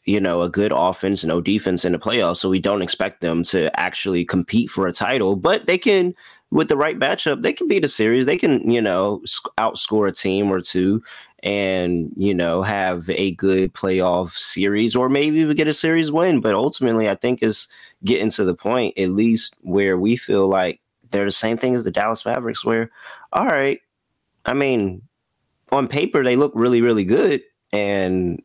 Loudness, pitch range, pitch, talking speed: -19 LUFS, 95-120 Hz, 100 Hz, 195 wpm